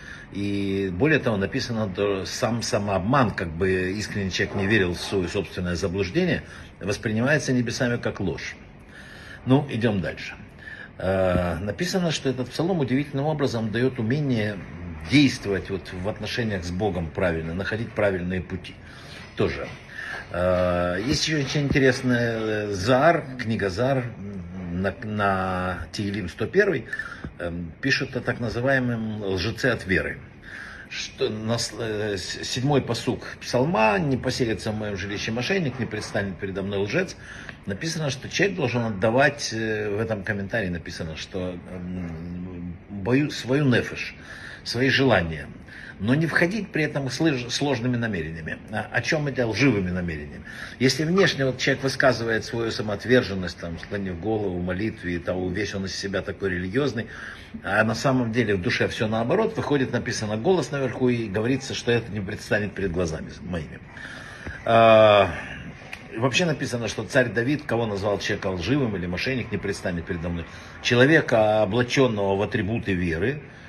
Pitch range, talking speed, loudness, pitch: 95-125 Hz, 135 wpm, -24 LUFS, 110 Hz